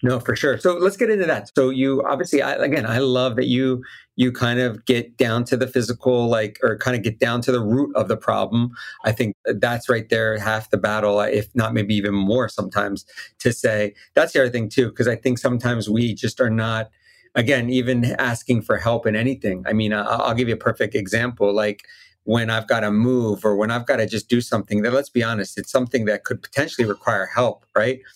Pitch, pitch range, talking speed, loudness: 120 Hz, 110-130 Hz, 230 wpm, -21 LUFS